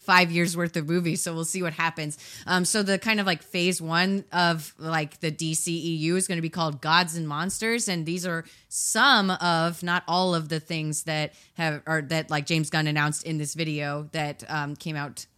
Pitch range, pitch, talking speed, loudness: 155-175 Hz, 165 Hz, 215 wpm, -25 LUFS